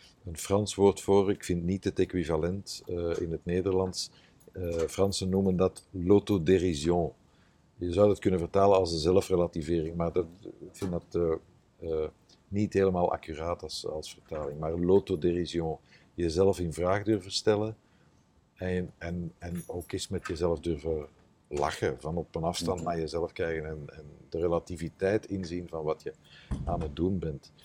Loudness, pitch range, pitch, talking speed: -30 LUFS, 85-95 Hz, 90 Hz, 160 wpm